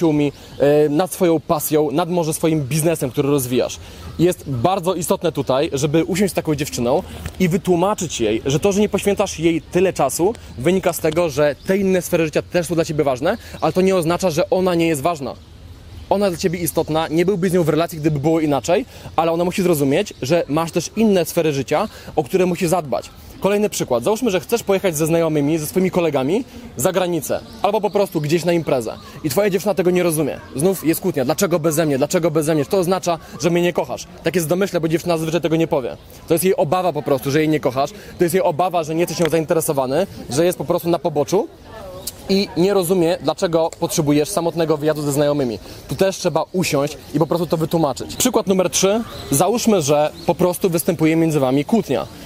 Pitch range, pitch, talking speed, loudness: 150-185 Hz, 170 Hz, 210 wpm, -19 LUFS